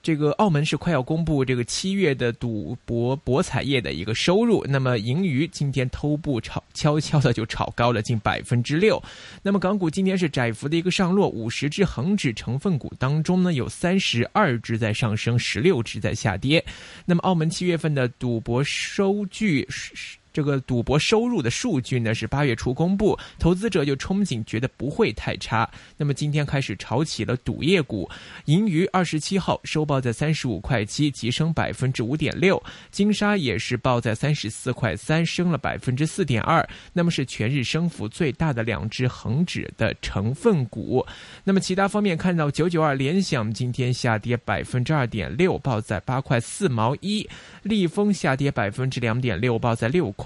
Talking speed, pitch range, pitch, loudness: 285 characters per minute, 120-170 Hz, 140 Hz, -23 LUFS